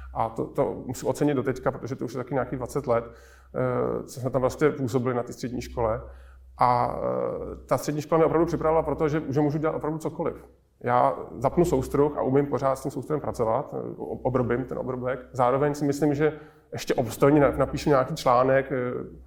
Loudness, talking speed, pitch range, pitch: -26 LUFS, 195 wpm, 125-150 Hz, 135 Hz